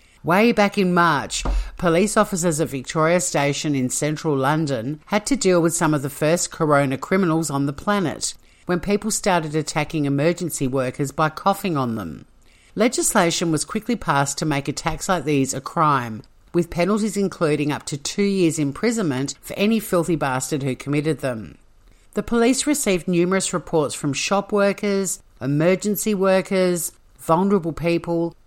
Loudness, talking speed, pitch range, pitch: -21 LUFS, 155 wpm, 145-190 Hz, 165 Hz